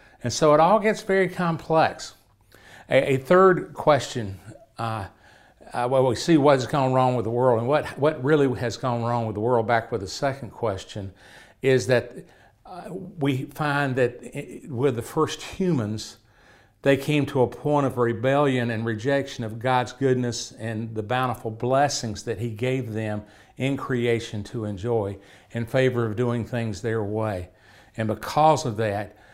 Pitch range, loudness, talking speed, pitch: 110-140 Hz, -24 LUFS, 170 wpm, 125 Hz